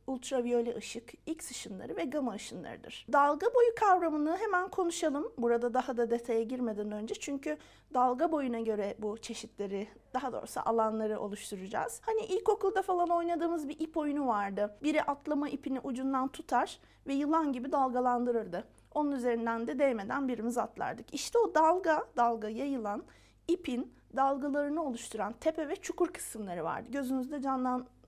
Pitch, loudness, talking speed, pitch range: 265 Hz, -33 LUFS, 140 wpm, 235-315 Hz